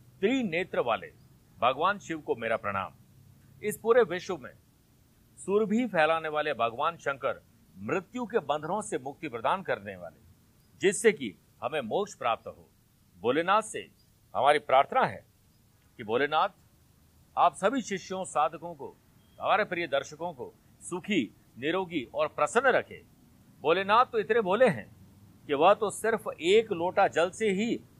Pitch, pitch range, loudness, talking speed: 175 Hz, 150-215 Hz, -29 LUFS, 140 wpm